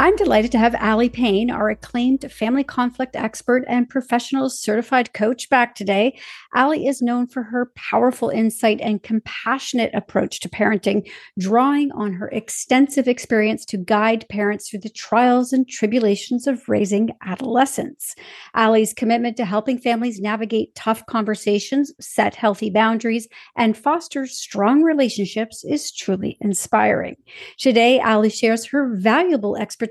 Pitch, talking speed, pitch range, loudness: 235 Hz, 140 wpm, 220-260 Hz, -19 LUFS